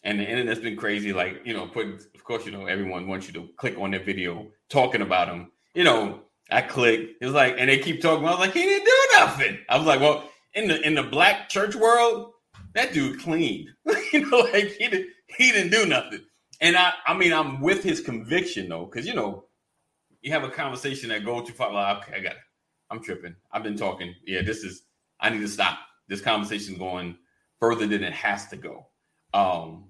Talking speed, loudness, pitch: 225 wpm, -23 LUFS, 125 Hz